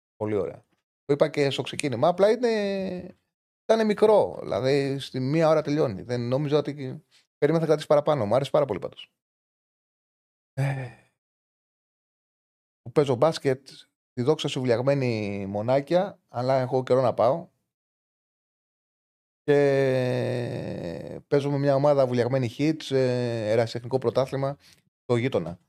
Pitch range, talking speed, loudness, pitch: 125-155 Hz, 120 wpm, -25 LUFS, 135 Hz